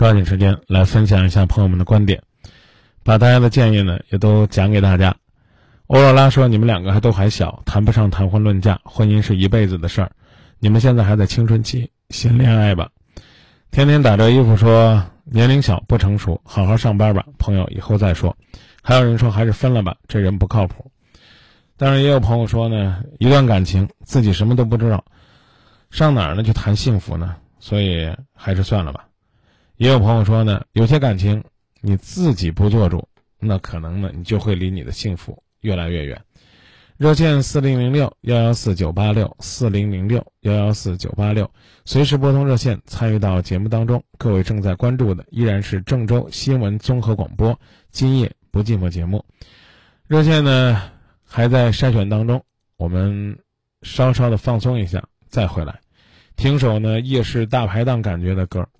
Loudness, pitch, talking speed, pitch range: -17 LUFS, 110 Hz, 275 characters per minute, 95-120 Hz